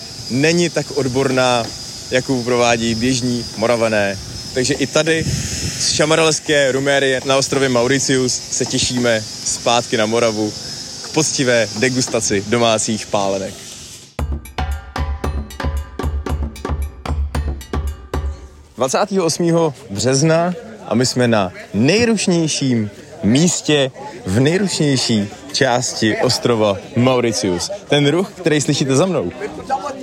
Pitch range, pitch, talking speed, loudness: 105-140 Hz, 125 Hz, 90 wpm, -17 LUFS